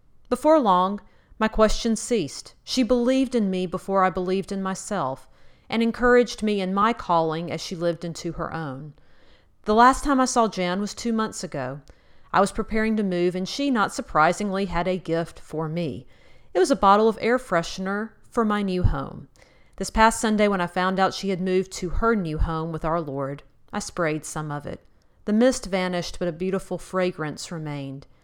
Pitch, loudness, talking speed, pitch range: 185 Hz, -24 LUFS, 195 wpm, 165-220 Hz